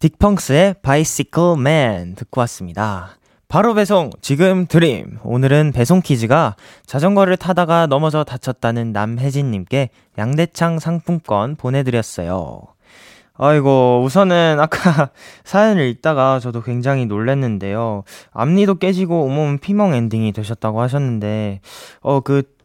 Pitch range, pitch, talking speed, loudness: 115-165 Hz, 140 Hz, 290 characters per minute, -16 LUFS